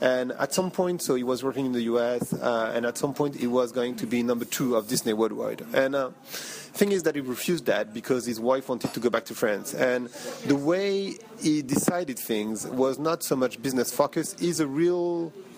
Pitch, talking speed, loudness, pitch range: 135 Hz, 225 wpm, -27 LUFS, 120-165 Hz